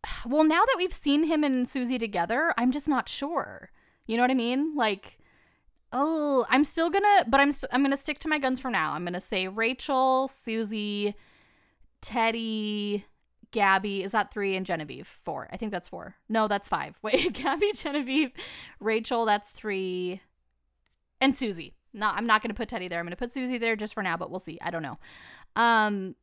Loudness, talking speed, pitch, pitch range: -27 LUFS, 200 wpm, 230 Hz, 200-275 Hz